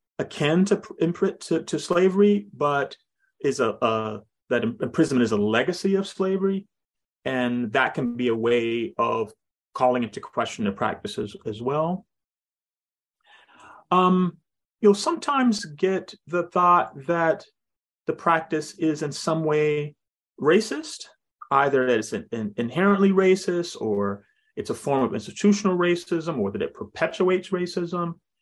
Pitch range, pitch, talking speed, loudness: 140-190 Hz, 170 Hz, 135 wpm, -24 LUFS